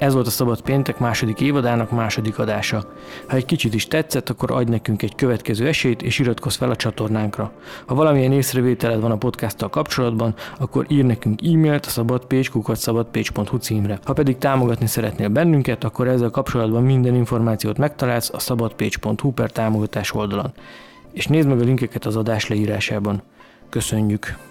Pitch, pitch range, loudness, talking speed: 120 Hz, 110-130 Hz, -20 LUFS, 155 wpm